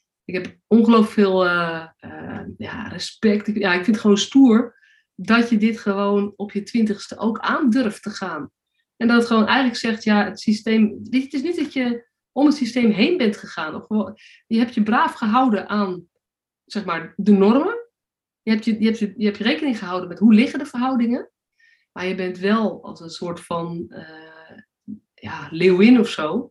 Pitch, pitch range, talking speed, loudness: 220 Hz, 200-240 Hz, 190 wpm, -19 LUFS